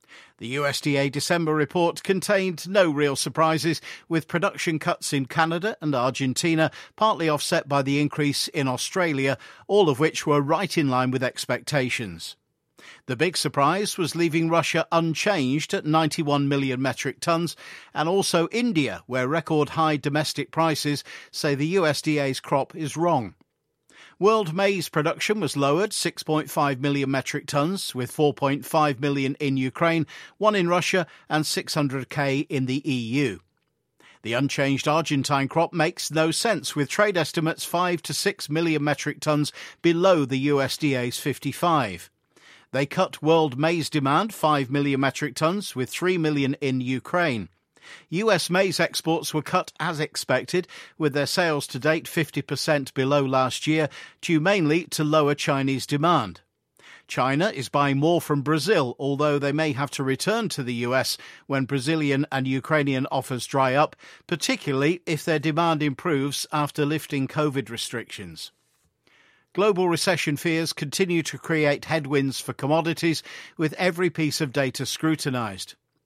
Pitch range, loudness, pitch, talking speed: 140-165 Hz, -24 LUFS, 150 Hz, 145 wpm